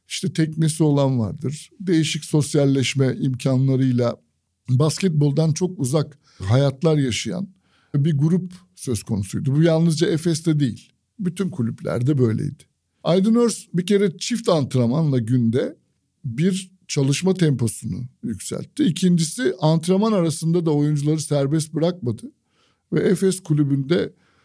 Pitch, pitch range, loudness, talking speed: 155 Hz, 135-175 Hz, -21 LUFS, 110 wpm